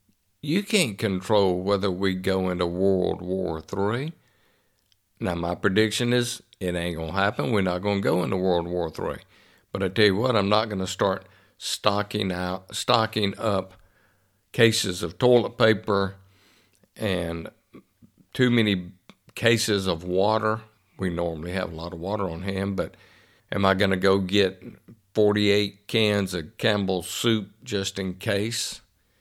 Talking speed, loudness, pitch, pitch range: 155 wpm, -25 LUFS, 100 Hz, 95-110 Hz